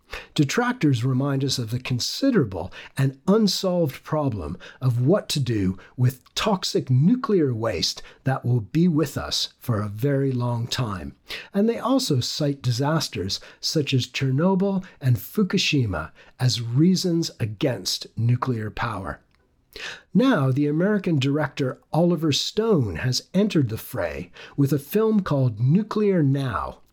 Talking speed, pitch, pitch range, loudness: 130 wpm, 140 Hz, 125-175 Hz, -23 LUFS